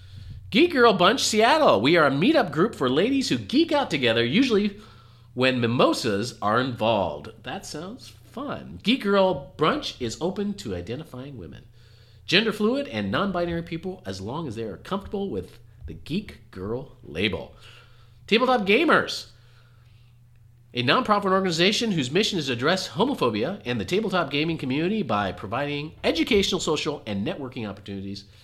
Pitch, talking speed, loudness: 140 Hz, 150 wpm, -23 LUFS